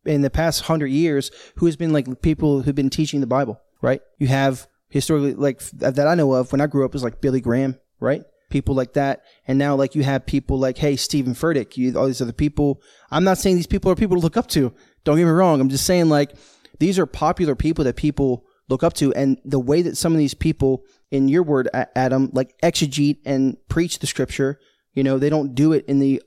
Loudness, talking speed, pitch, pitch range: -20 LUFS, 240 wpm, 140 Hz, 135-155 Hz